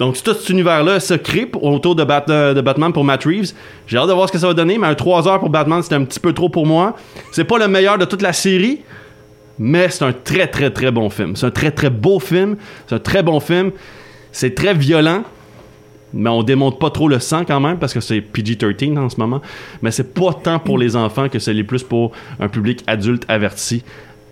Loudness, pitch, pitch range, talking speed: -15 LUFS, 145 Hz, 120-180 Hz, 240 wpm